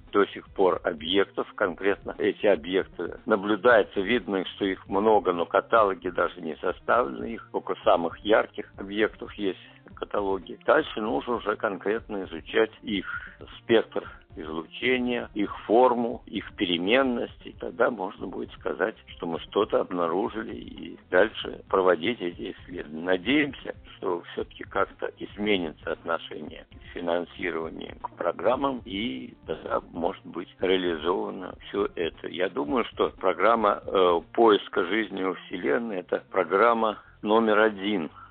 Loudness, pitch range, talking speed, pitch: -26 LUFS, 95-120 Hz, 120 wpm, 105 Hz